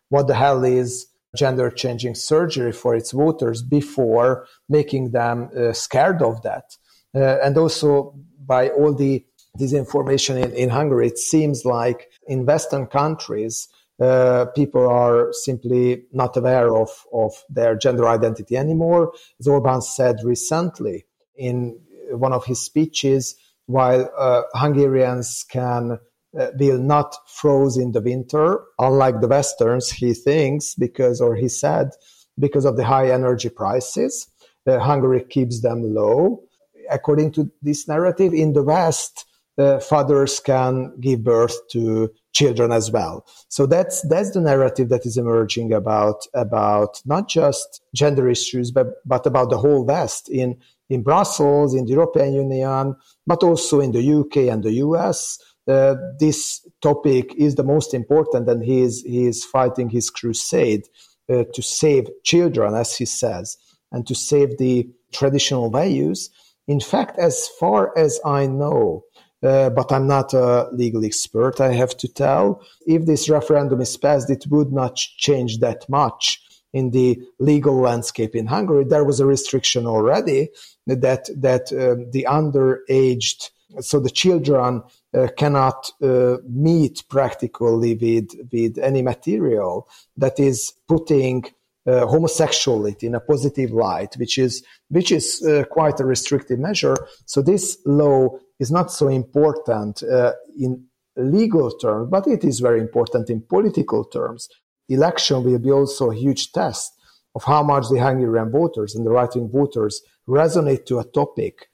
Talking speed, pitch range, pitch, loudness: 150 wpm, 125-145 Hz, 130 Hz, -19 LUFS